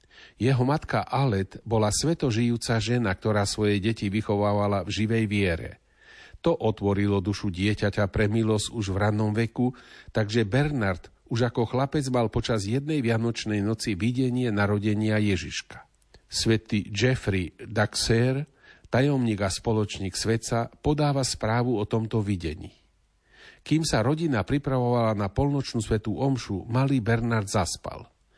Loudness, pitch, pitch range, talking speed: -26 LUFS, 110 Hz, 105-125 Hz, 125 wpm